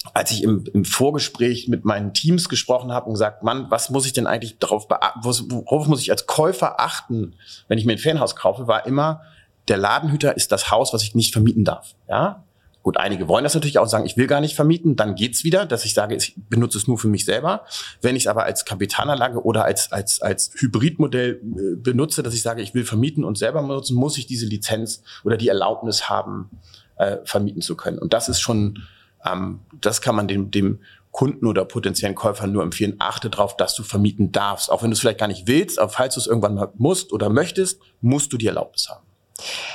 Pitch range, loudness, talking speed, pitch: 105-130 Hz, -20 LUFS, 220 wpm, 115 Hz